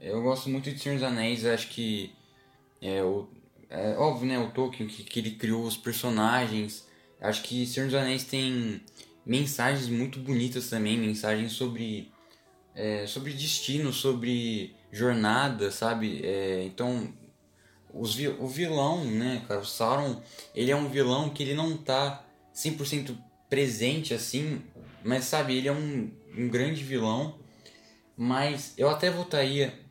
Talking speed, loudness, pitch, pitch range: 145 wpm, -29 LUFS, 125 Hz, 110-140 Hz